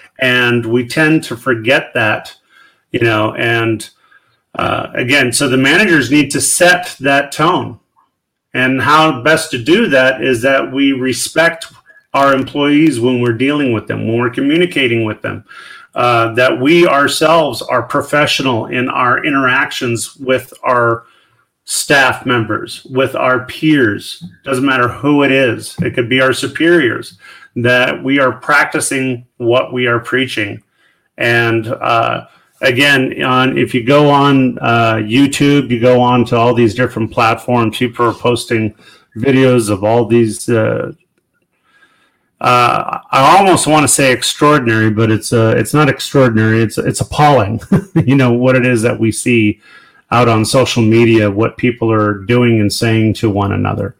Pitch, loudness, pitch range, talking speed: 125 Hz, -12 LUFS, 115-140 Hz, 155 wpm